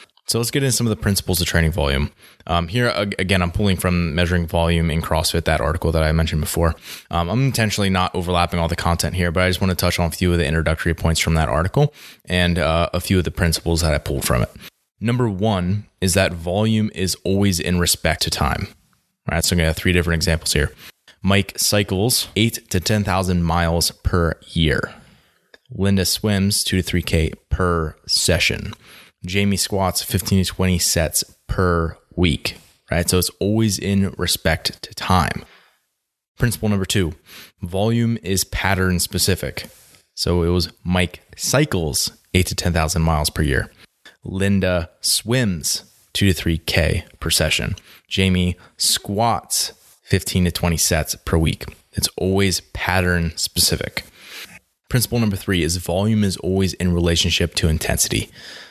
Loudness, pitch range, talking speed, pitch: -19 LUFS, 85-100 Hz, 170 wpm, 90 Hz